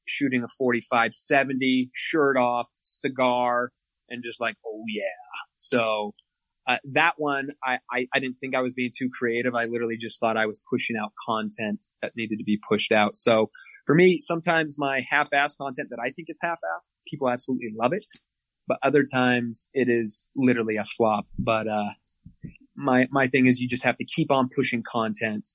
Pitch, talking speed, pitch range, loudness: 125 Hz, 185 wpm, 115-135 Hz, -25 LUFS